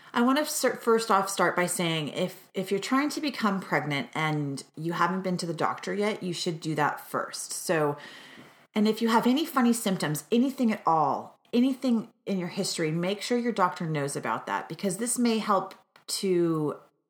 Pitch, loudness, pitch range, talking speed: 190 Hz, -28 LUFS, 170-230 Hz, 195 wpm